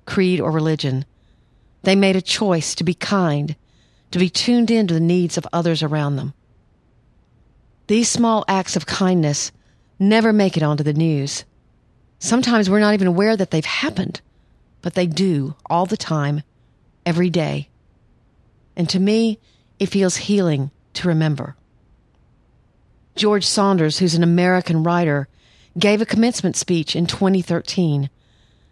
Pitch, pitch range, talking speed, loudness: 175 Hz, 150-195 Hz, 140 wpm, -19 LUFS